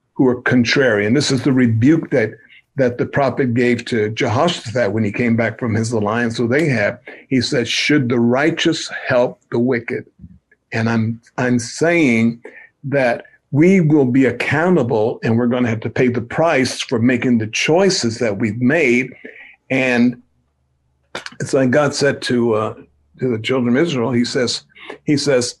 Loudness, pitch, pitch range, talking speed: -17 LUFS, 120 Hz, 115-135 Hz, 175 wpm